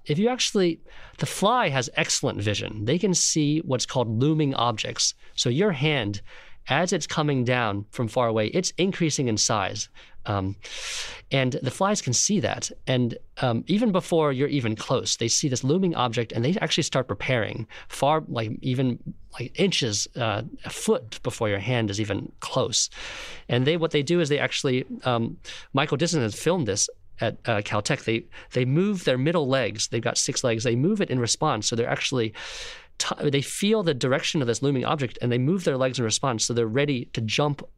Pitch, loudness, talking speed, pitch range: 130 Hz, -24 LUFS, 195 wpm, 115-160 Hz